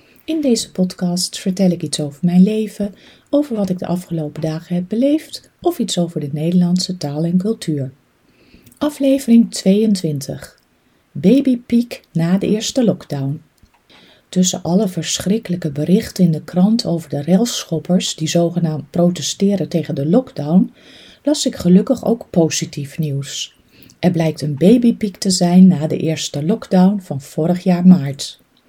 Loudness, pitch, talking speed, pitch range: -17 LUFS, 180 Hz, 140 wpm, 160-210 Hz